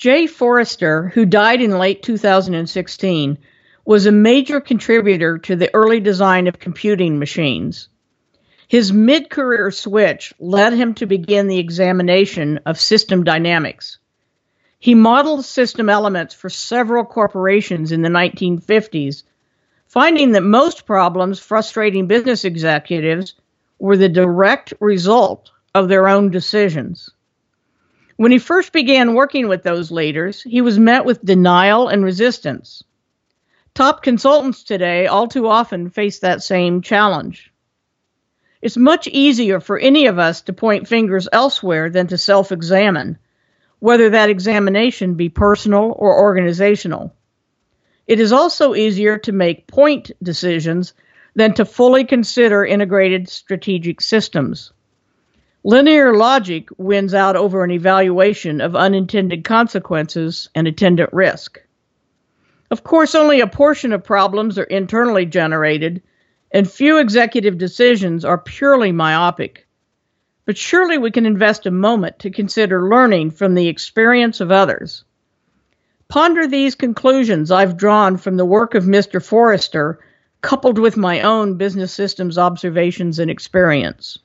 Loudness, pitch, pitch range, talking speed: -14 LUFS, 200 Hz, 180-230 Hz, 130 wpm